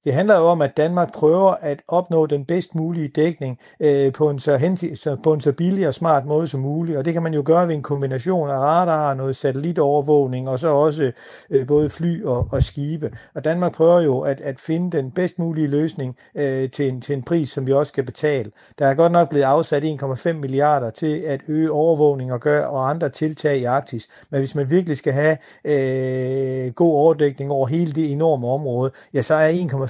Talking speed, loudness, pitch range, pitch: 215 wpm, -19 LUFS, 135-160 Hz, 150 Hz